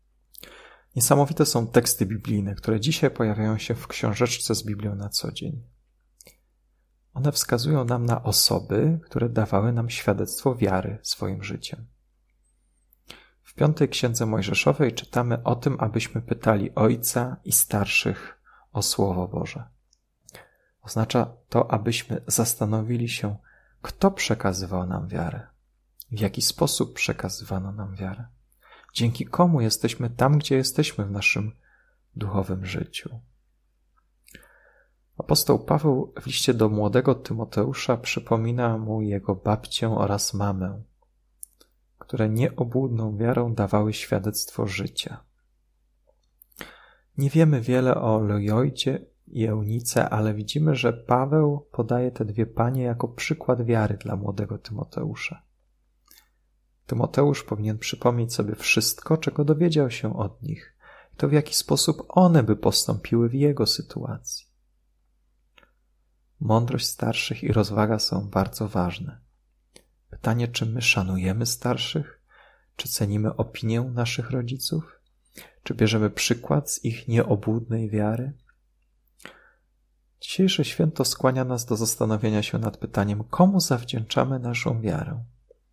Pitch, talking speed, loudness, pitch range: 115 Hz, 115 wpm, -24 LUFS, 100-130 Hz